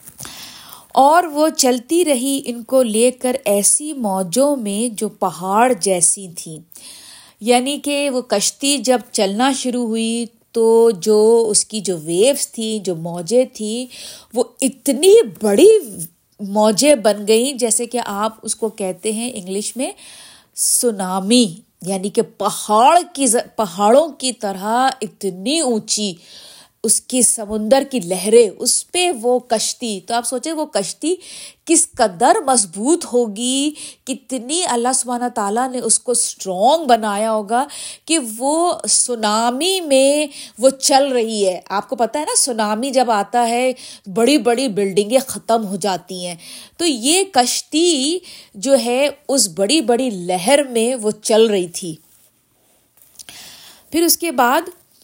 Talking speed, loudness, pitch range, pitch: 140 wpm, -16 LUFS, 215-275 Hz, 240 Hz